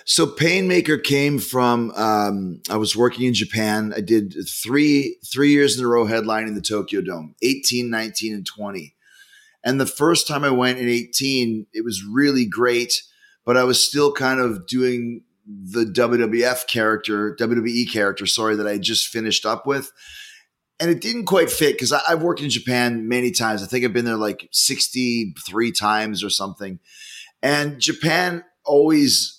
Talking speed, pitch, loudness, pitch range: 165 wpm, 120 Hz, -19 LUFS, 110-145 Hz